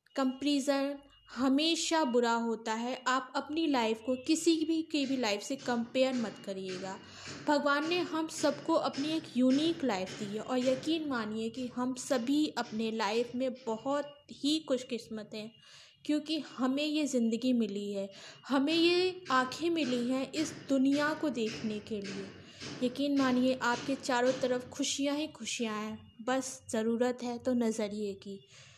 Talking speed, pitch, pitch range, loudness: 150 wpm, 255 Hz, 230-290 Hz, -32 LUFS